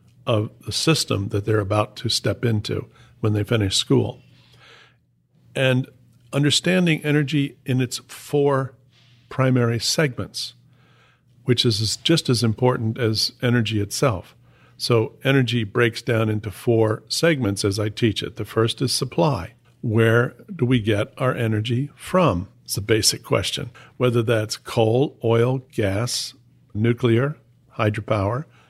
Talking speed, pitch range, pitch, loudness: 130 wpm, 110-130 Hz, 120 Hz, -21 LUFS